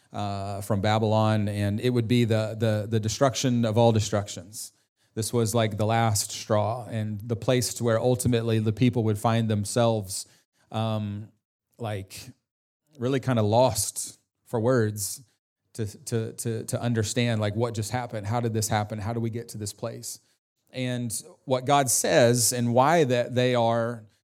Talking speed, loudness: 170 wpm, -26 LUFS